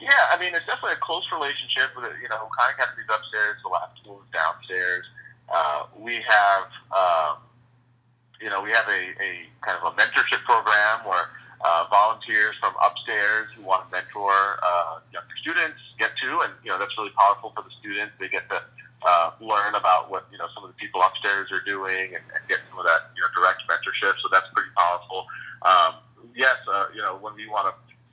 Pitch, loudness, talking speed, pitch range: 110 Hz, -23 LUFS, 205 wpm, 100-140 Hz